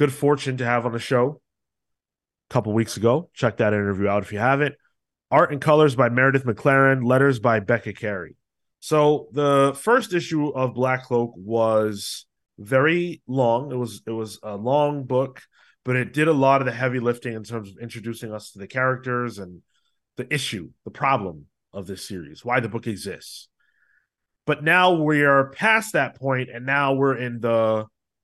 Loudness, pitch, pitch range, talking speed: -21 LUFS, 125 Hz, 110-135 Hz, 185 wpm